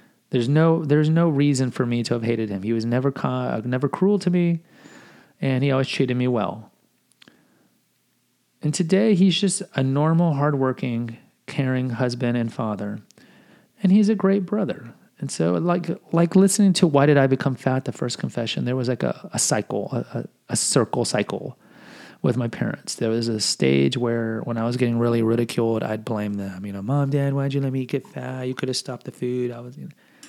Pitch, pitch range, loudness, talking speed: 130 Hz, 120-165 Hz, -22 LUFS, 200 wpm